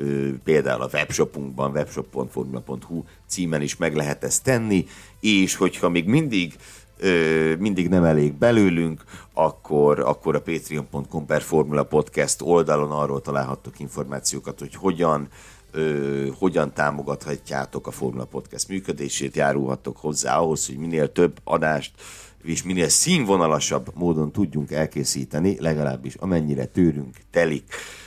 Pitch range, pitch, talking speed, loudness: 70-85 Hz, 75 Hz, 115 wpm, -23 LUFS